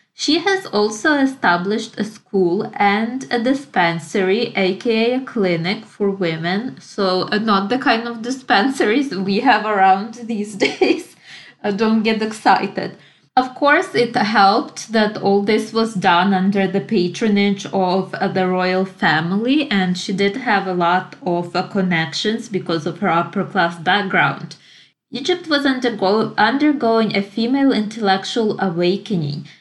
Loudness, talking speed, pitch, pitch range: -18 LUFS, 140 wpm, 205 Hz, 185-235 Hz